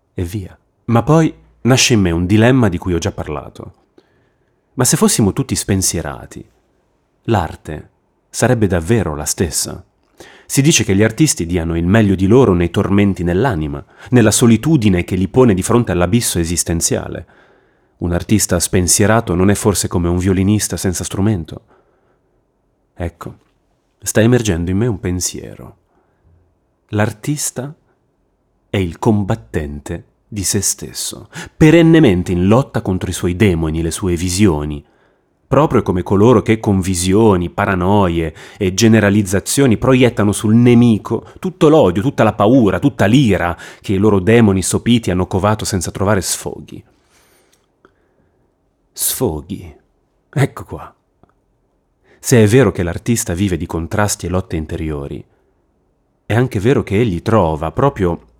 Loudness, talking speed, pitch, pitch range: -14 LUFS, 135 wpm, 100 Hz, 90-115 Hz